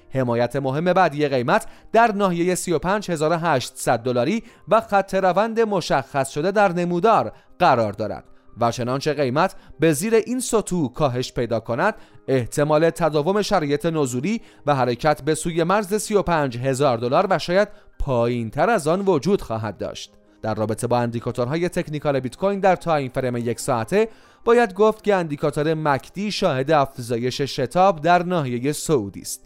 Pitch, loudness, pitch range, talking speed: 155 Hz, -21 LUFS, 130-190 Hz, 145 wpm